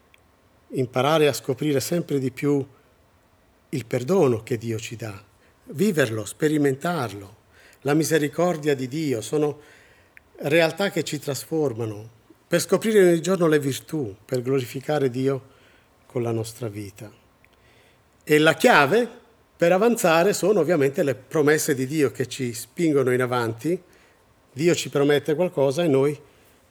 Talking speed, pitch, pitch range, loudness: 130 wpm, 135 Hz, 115-155 Hz, -22 LUFS